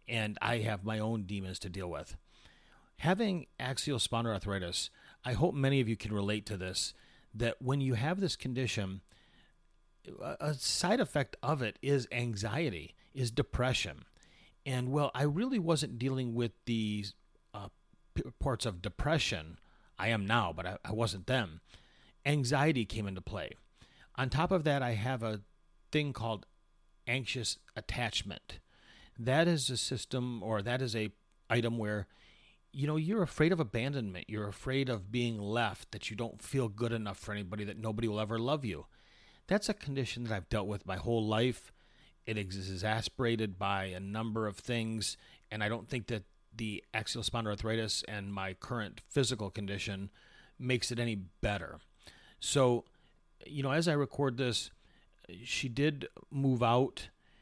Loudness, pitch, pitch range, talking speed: -35 LUFS, 115 Hz, 105-130 Hz, 160 wpm